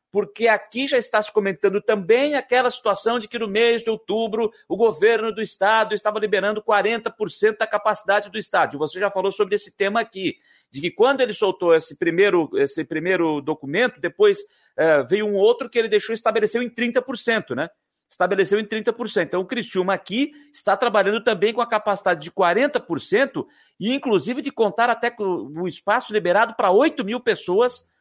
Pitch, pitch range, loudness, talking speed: 220 Hz, 200-240 Hz, -21 LUFS, 180 wpm